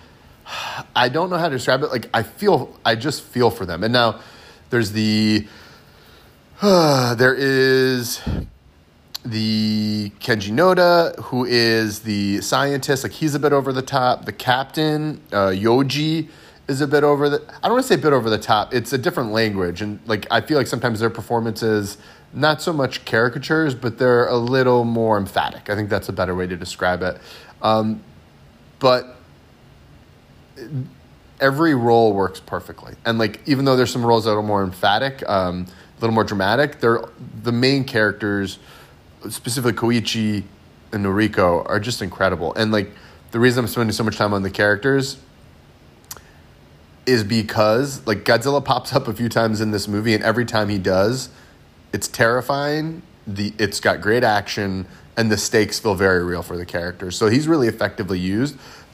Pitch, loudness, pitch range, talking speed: 115 Hz, -19 LUFS, 105-130 Hz, 170 wpm